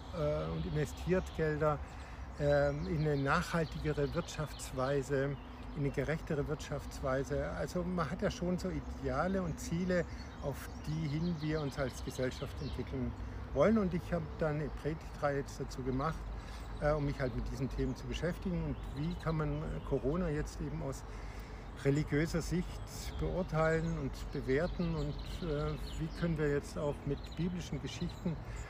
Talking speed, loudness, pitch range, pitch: 140 wpm, -37 LUFS, 130-160 Hz, 145 Hz